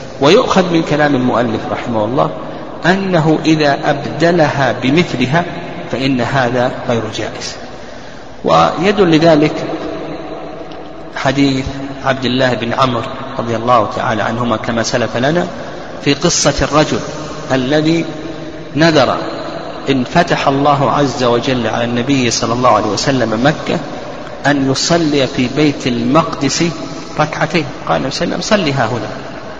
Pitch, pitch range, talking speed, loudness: 140 Hz, 125-155 Hz, 110 wpm, -14 LUFS